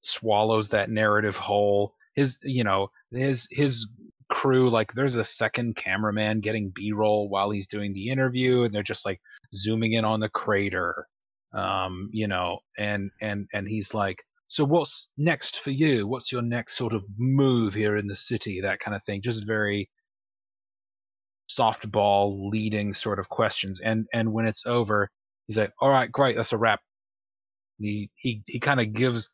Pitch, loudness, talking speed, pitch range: 110 Hz, -25 LUFS, 170 wpm, 105-125 Hz